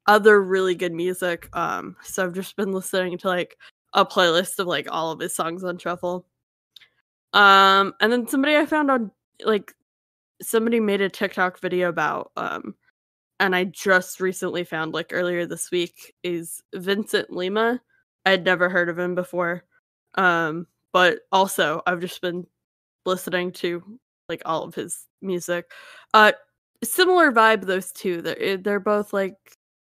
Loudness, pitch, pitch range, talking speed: -22 LUFS, 185 Hz, 180-205 Hz, 155 wpm